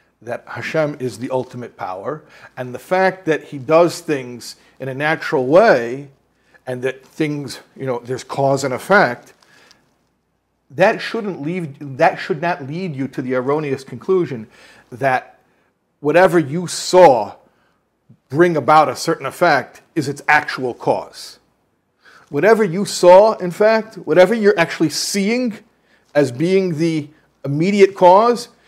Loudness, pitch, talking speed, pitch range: -16 LUFS, 160 Hz, 135 wpm, 135-185 Hz